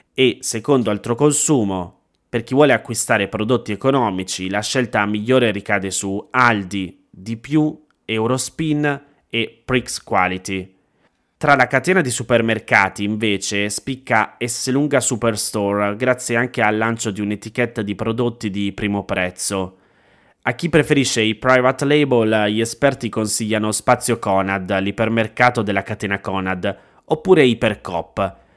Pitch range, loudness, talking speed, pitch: 100-125 Hz, -18 LUFS, 120 wpm, 110 Hz